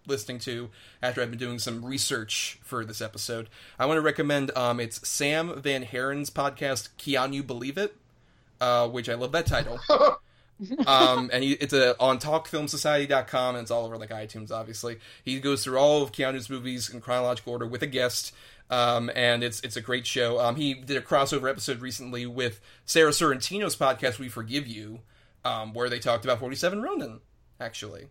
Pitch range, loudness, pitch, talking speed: 120-140 Hz, -27 LUFS, 125 Hz, 185 wpm